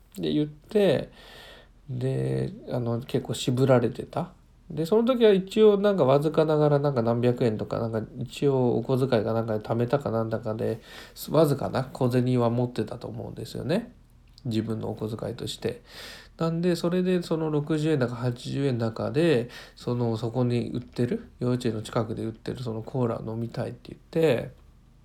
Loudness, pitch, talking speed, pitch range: -26 LUFS, 125 Hz, 325 characters per minute, 115-150 Hz